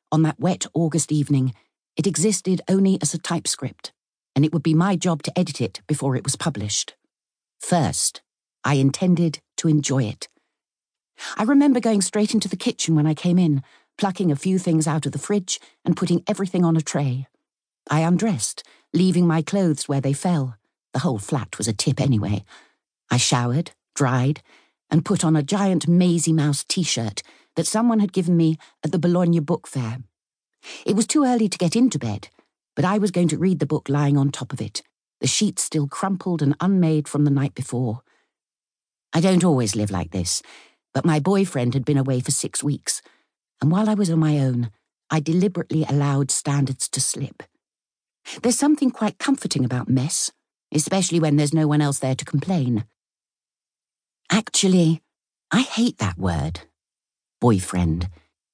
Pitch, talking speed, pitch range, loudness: 155 Hz, 175 wpm, 135-185 Hz, -21 LUFS